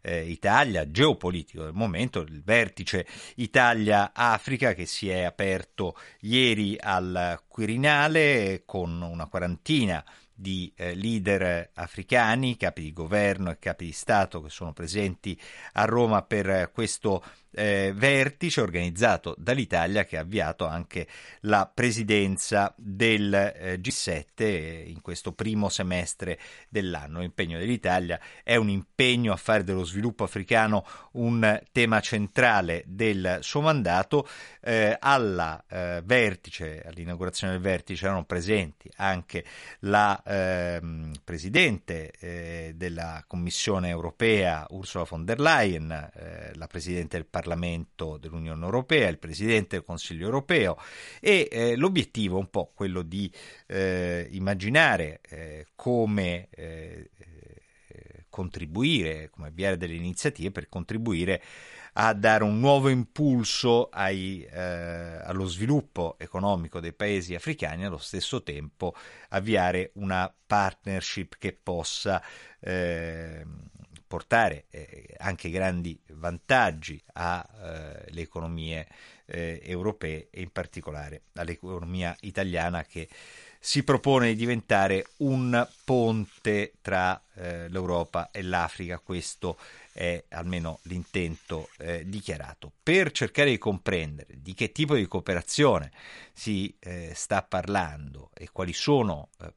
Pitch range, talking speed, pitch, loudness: 85-105 Hz, 115 wpm, 95 Hz, -27 LUFS